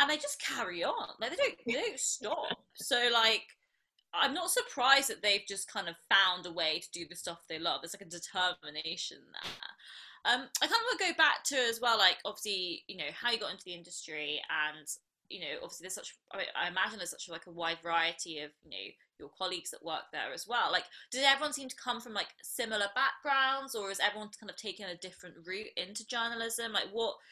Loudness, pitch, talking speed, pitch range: -33 LUFS, 200 Hz, 230 wpm, 175-250 Hz